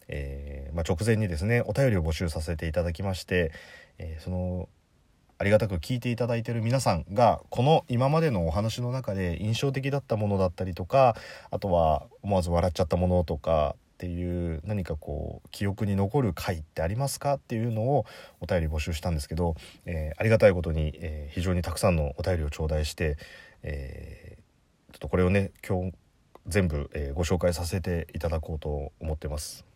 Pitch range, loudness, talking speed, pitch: 80-110 Hz, -28 LUFS, 380 characters per minute, 90 Hz